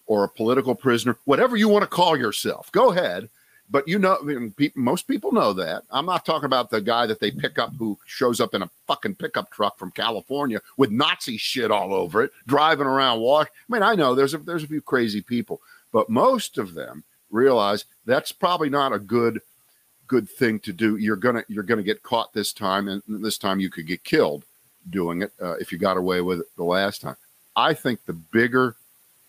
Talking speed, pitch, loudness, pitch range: 220 wpm, 120 Hz, -23 LUFS, 105-145 Hz